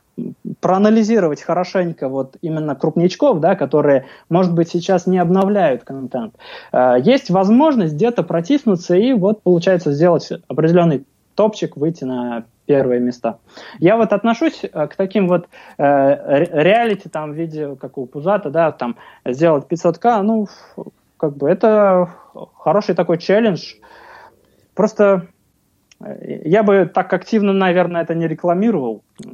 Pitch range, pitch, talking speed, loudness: 150-200 Hz, 175 Hz, 125 wpm, -16 LUFS